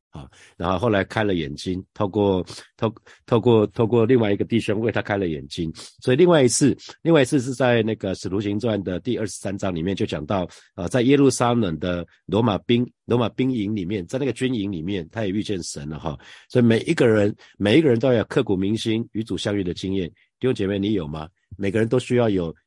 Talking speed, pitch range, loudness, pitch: 330 characters per minute, 95-120 Hz, -22 LUFS, 105 Hz